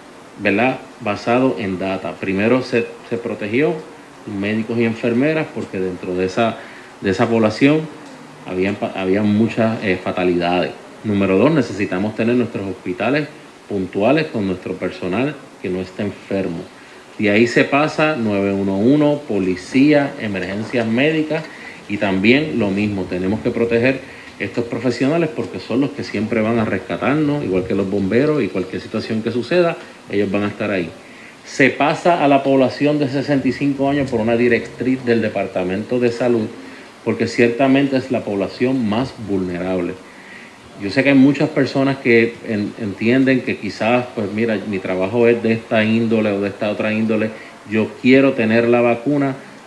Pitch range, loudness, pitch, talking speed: 100-130 Hz, -18 LUFS, 115 Hz, 150 wpm